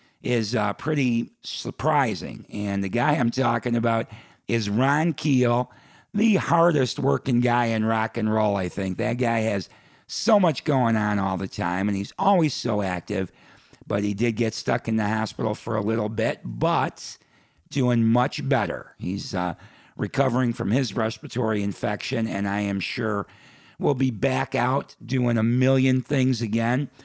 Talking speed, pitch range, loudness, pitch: 165 wpm, 105-130 Hz, -24 LUFS, 115 Hz